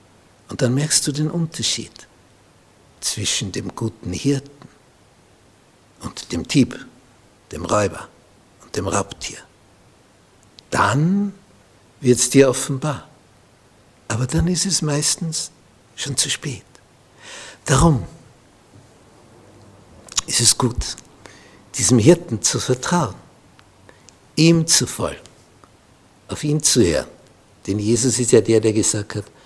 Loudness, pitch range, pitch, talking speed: -19 LUFS, 105-150 Hz, 125 Hz, 110 wpm